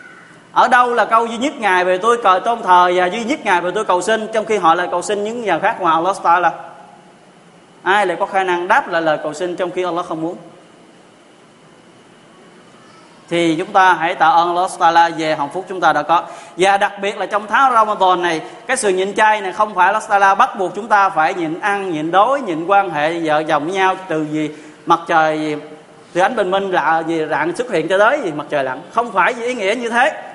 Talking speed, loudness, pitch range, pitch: 240 wpm, -16 LUFS, 165-210 Hz, 185 Hz